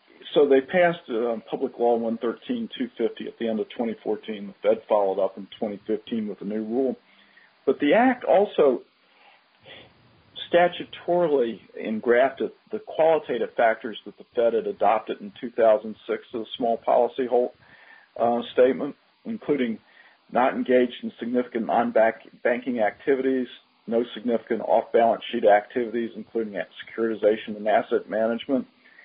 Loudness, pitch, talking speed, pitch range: -24 LUFS, 120 Hz, 130 wpm, 110-160 Hz